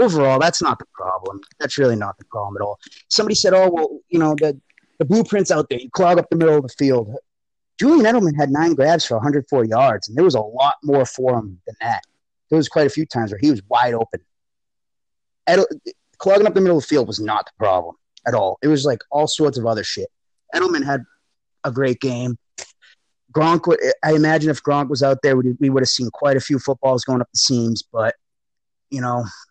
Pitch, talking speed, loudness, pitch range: 140 Hz, 220 wpm, -18 LUFS, 125-165 Hz